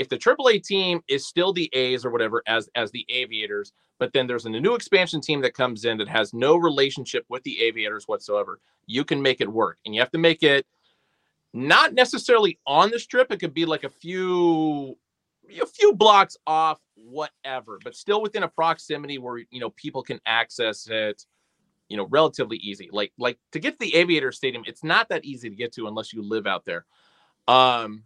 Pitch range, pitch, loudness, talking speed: 120-195 Hz, 150 Hz, -22 LUFS, 205 wpm